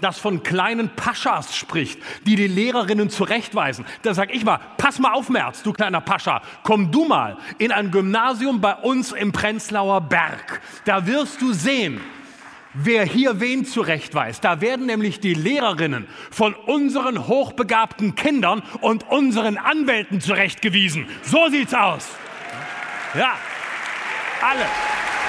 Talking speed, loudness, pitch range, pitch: 135 wpm, -20 LUFS, 200-255 Hz, 220 Hz